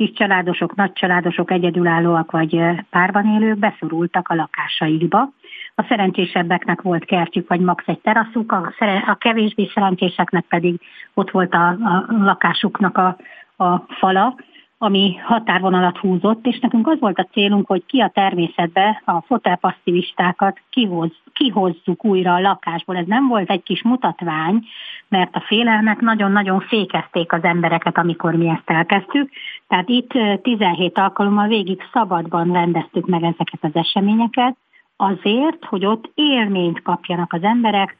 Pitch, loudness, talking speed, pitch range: 190 Hz, -17 LUFS, 135 wpm, 175-215 Hz